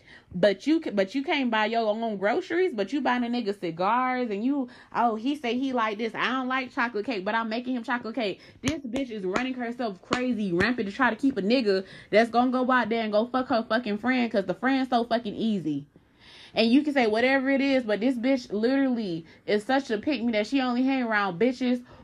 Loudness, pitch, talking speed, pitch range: -26 LUFS, 235 Hz, 235 wpm, 210-260 Hz